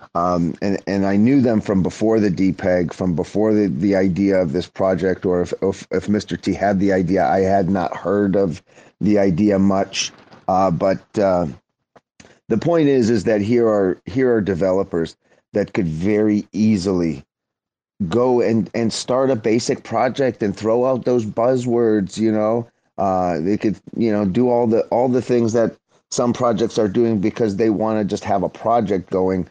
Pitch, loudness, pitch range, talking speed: 105 Hz, -19 LUFS, 95-115 Hz, 185 wpm